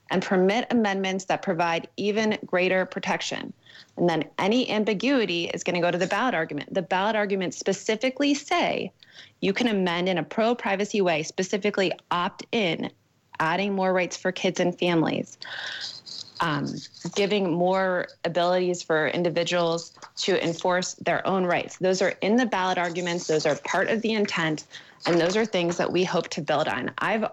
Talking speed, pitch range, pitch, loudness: 170 wpm, 175-205 Hz, 185 Hz, -25 LUFS